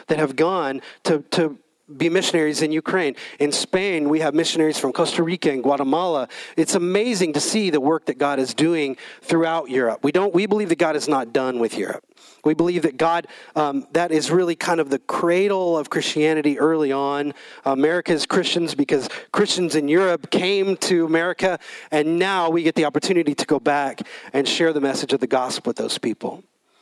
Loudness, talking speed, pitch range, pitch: -21 LUFS, 190 wpm, 145-175 Hz, 160 Hz